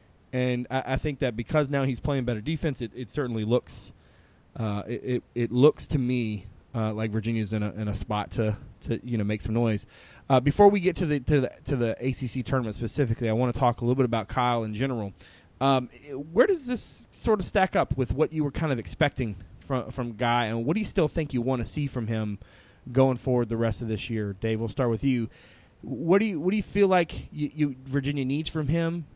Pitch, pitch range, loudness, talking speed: 125 Hz, 115-145 Hz, -27 LUFS, 235 wpm